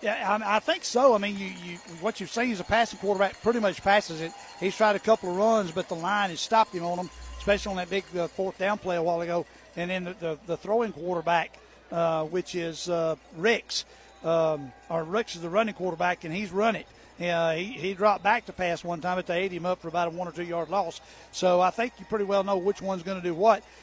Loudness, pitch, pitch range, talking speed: -27 LUFS, 185 Hz, 170-205 Hz, 260 wpm